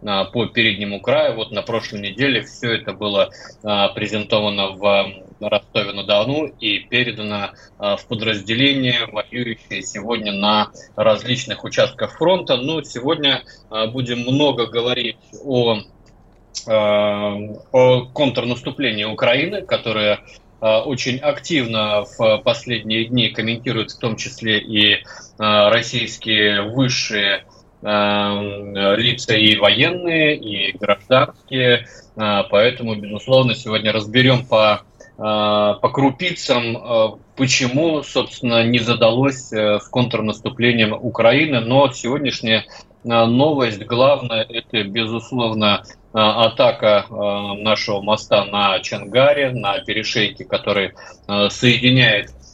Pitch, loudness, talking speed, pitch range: 110 Hz, -17 LUFS, 95 wpm, 105-125 Hz